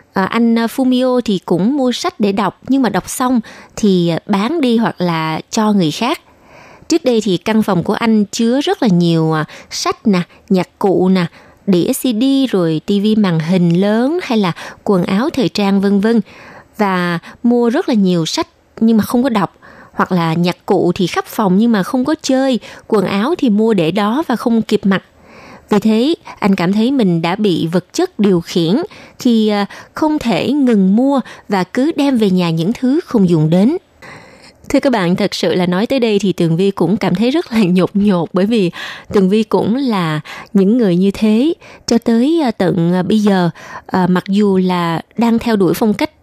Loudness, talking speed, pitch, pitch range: -14 LUFS, 200 wpm, 210 Hz, 185-240 Hz